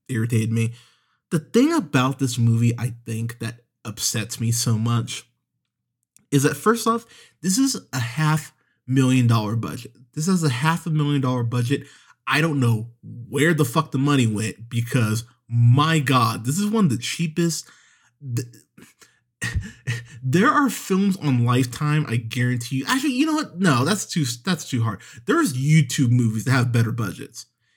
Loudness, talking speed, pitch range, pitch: -22 LUFS, 165 wpm, 120-155 Hz, 130 Hz